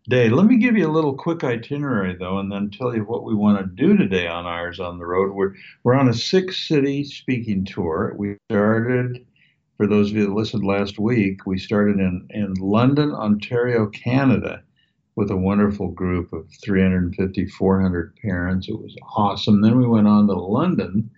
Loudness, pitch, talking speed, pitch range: -20 LUFS, 105 Hz, 190 wpm, 95-120 Hz